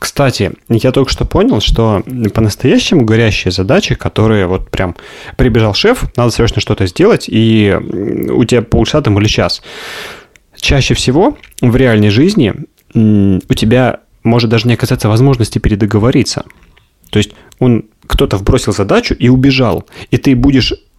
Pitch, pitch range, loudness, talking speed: 115 Hz, 105-130 Hz, -11 LUFS, 140 wpm